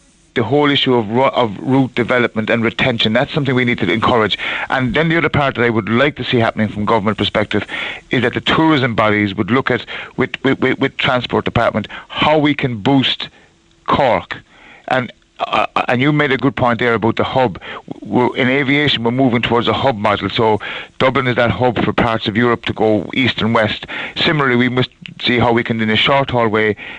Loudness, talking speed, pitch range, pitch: -15 LUFS, 210 wpm, 115-135 Hz, 125 Hz